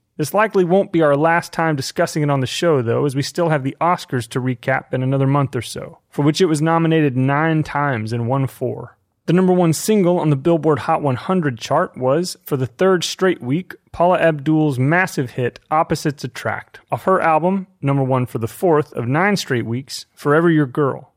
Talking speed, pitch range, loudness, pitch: 205 wpm, 130-170 Hz, -18 LUFS, 150 Hz